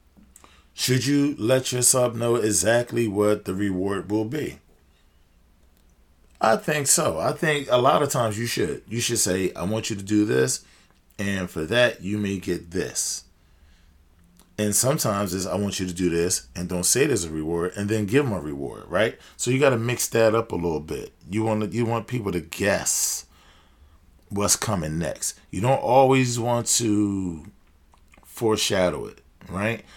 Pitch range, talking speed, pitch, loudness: 85-115 Hz, 175 wpm, 100 Hz, -23 LUFS